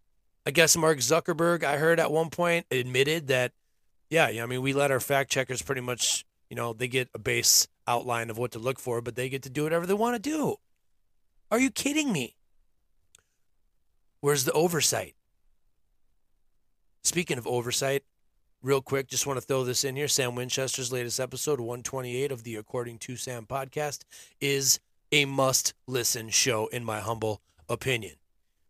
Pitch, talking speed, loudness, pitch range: 130 Hz, 170 wpm, -27 LUFS, 120-145 Hz